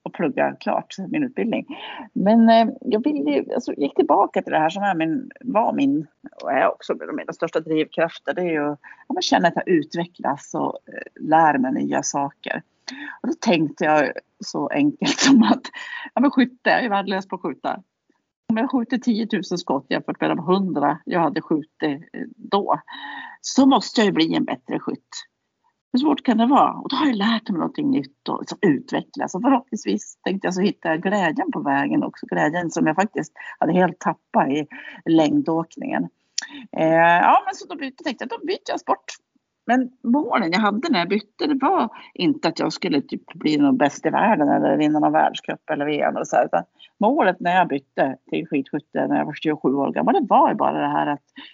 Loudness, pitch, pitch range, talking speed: -21 LUFS, 235 Hz, 170-285 Hz, 200 wpm